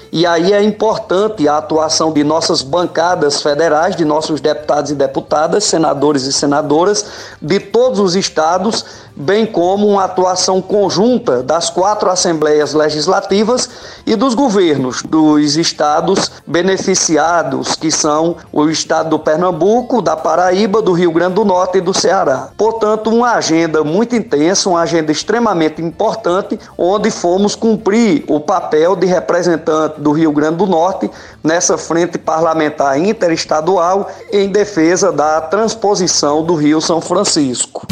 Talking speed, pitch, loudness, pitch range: 135 wpm, 175 Hz, -13 LUFS, 155-205 Hz